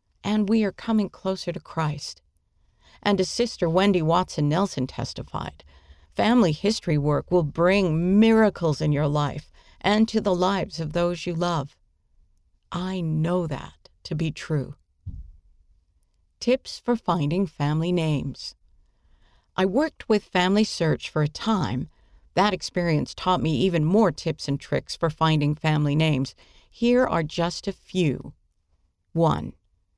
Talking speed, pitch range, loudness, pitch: 140 wpm, 135-190 Hz, -24 LUFS, 165 Hz